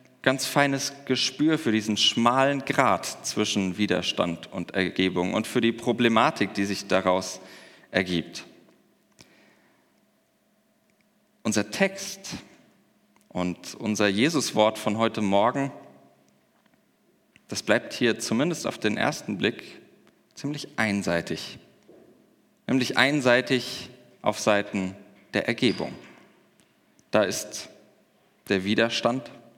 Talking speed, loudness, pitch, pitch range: 95 wpm, -25 LUFS, 110 Hz, 95-130 Hz